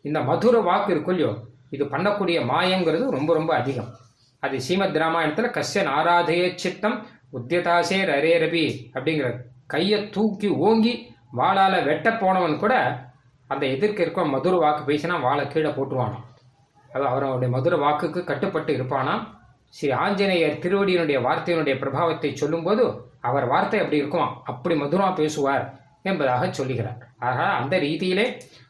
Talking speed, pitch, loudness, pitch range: 125 wpm, 150 Hz, -23 LUFS, 130-180 Hz